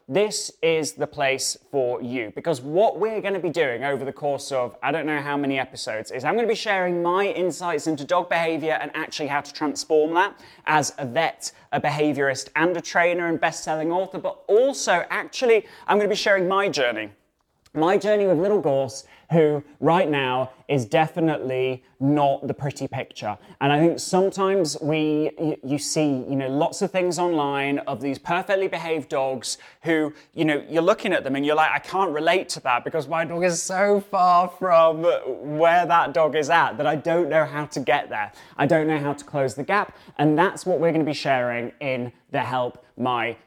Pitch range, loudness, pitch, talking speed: 140-175 Hz, -23 LUFS, 155 Hz, 205 wpm